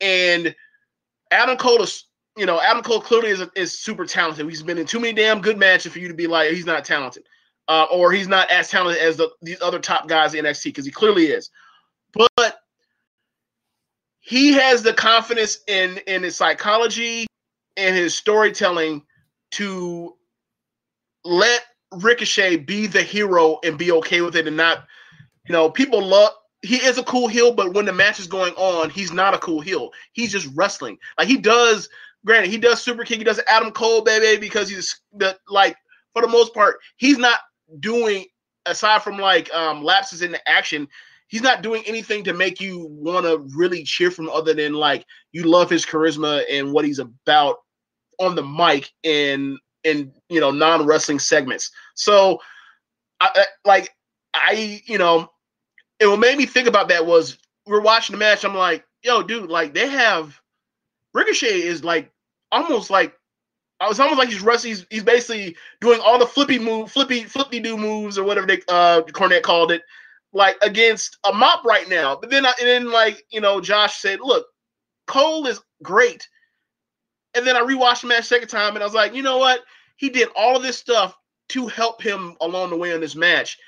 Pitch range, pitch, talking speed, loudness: 170-235 Hz, 200 Hz, 190 wpm, -18 LUFS